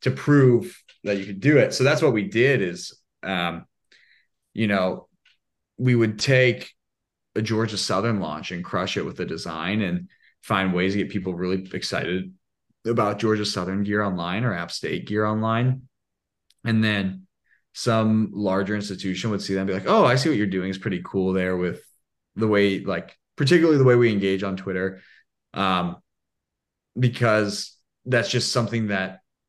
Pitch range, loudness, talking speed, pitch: 95-115 Hz, -23 LUFS, 175 wpm, 100 Hz